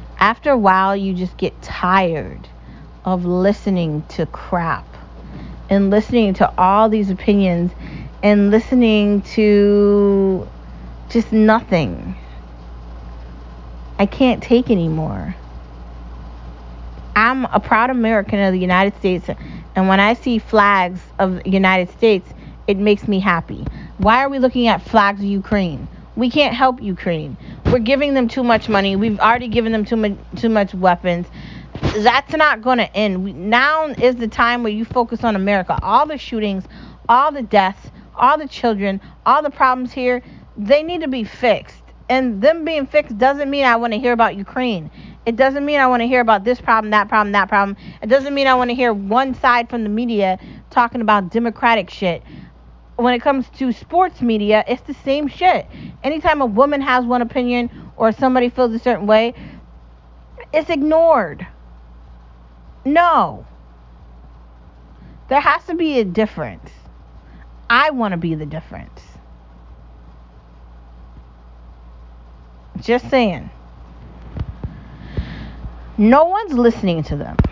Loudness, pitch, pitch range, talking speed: -16 LUFS, 205 Hz, 150-245 Hz, 150 wpm